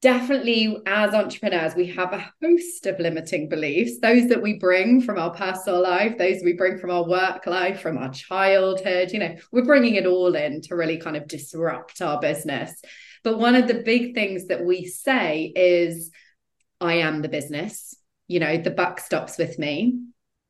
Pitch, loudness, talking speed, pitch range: 185 Hz, -22 LUFS, 185 wpm, 170-215 Hz